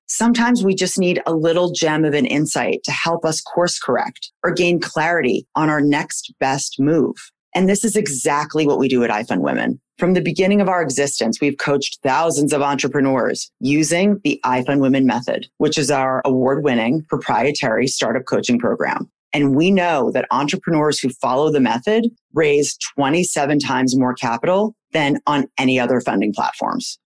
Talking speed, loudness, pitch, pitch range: 170 wpm, -18 LUFS, 150 Hz, 135-175 Hz